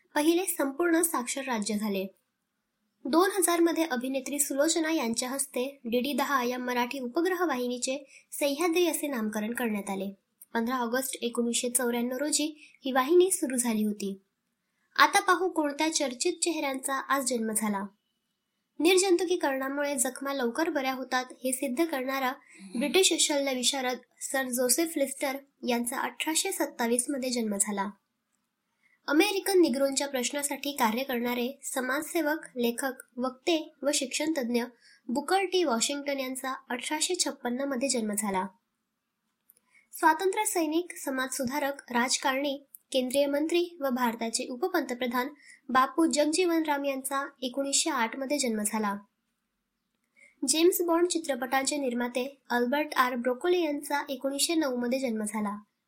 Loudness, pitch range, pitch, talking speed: -28 LUFS, 240-300 Hz, 270 Hz, 115 wpm